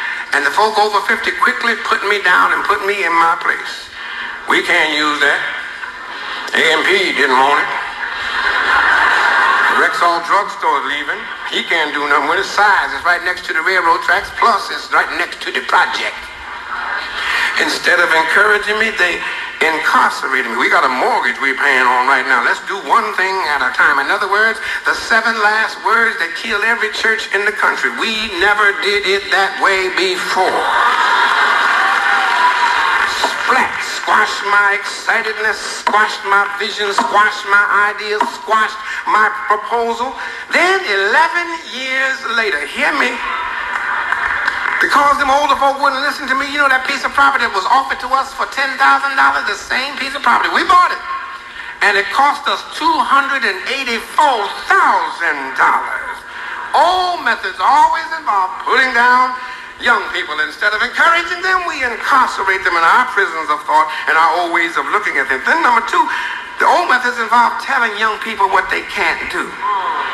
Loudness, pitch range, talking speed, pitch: -13 LUFS, 205-335 Hz, 160 wpm, 245 Hz